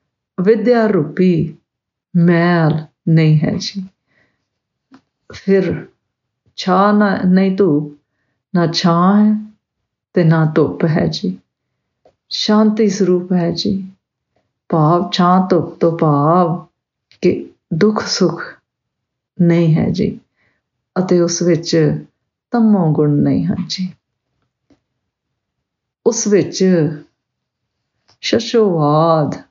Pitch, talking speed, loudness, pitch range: 175 Hz, 85 wpm, -15 LUFS, 155-195 Hz